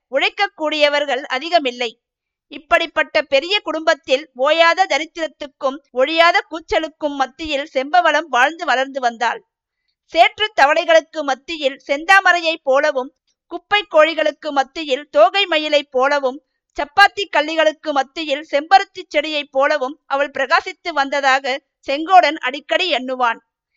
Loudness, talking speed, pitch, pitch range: -17 LUFS, 95 wpm, 300 Hz, 270-330 Hz